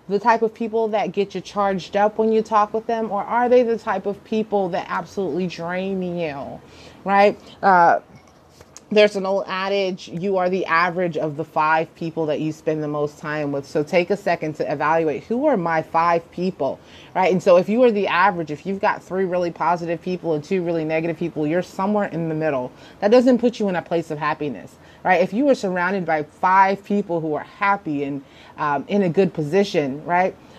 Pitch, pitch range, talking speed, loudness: 180 Hz, 160-200 Hz, 215 wpm, -21 LUFS